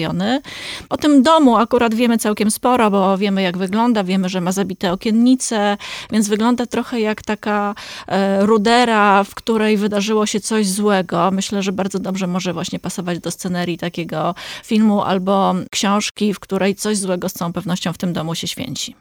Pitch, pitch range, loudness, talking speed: 205 Hz, 185-220 Hz, -17 LUFS, 165 wpm